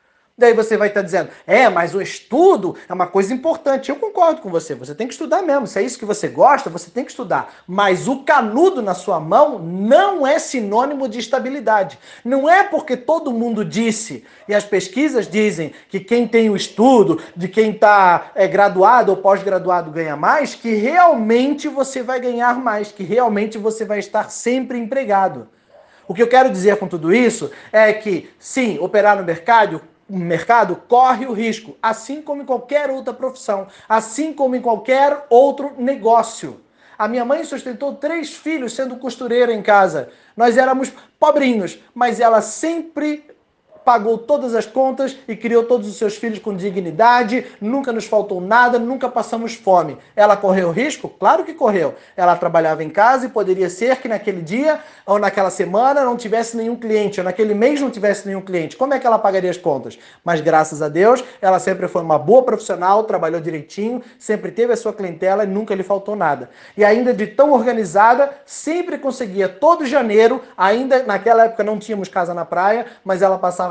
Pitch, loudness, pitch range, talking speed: 225 Hz, -16 LUFS, 195-260 Hz, 185 wpm